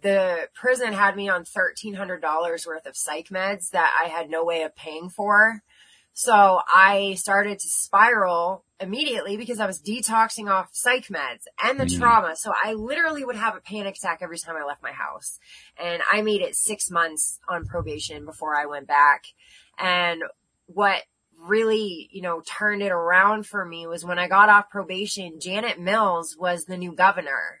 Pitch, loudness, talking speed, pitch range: 190 Hz, -22 LUFS, 180 wpm, 170-210 Hz